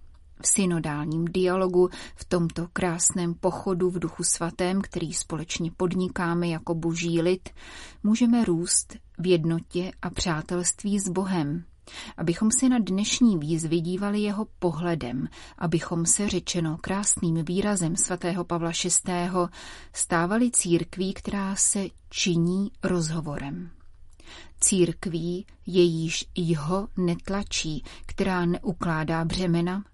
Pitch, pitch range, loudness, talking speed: 175 Hz, 170-190 Hz, -26 LUFS, 105 wpm